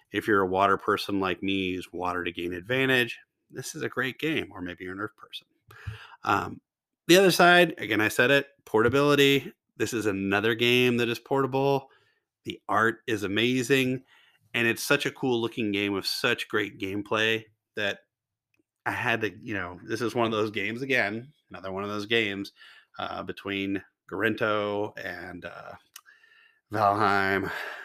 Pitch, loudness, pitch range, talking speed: 115 Hz, -26 LUFS, 100-135 Hz, 170 wpm